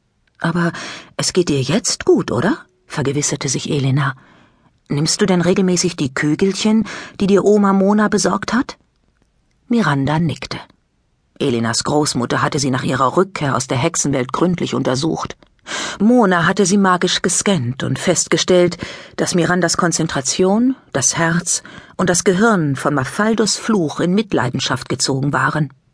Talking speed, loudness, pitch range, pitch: 135 wpm, -16 LUFS, 145-195 Hz, 170 Hz